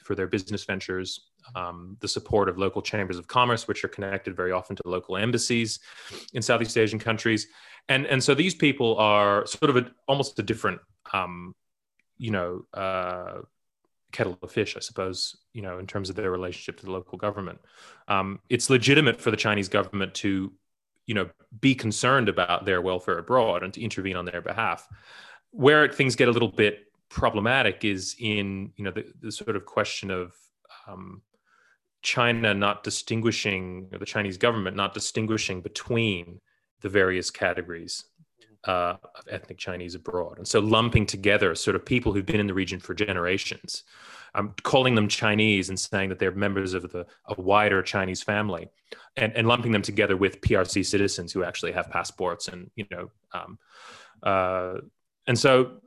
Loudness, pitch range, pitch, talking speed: -25 LUFS, 95-115 Hz, 100 Hz, 175 wpm